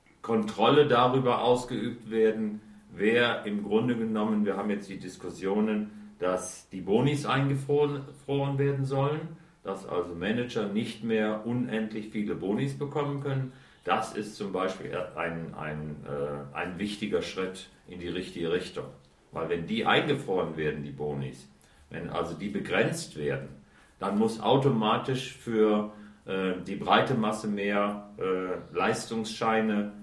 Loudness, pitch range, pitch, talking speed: -29 LUFS, 90-125 Hz, 105 Hz, 135 wpm